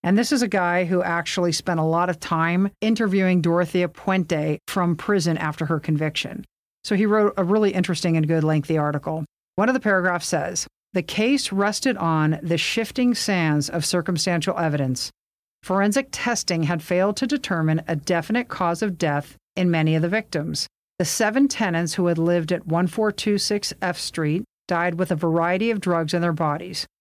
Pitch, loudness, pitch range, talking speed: 180 Hz, -22 LUFS, 165-205 Hz, 180 wpm